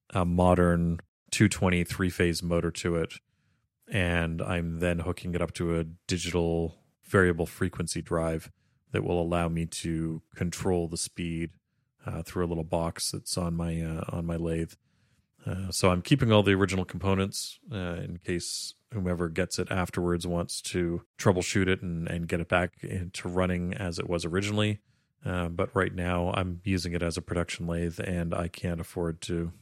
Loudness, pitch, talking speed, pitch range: -29 LUFS, 90 Hz, 175 wpm, 85-95 Hz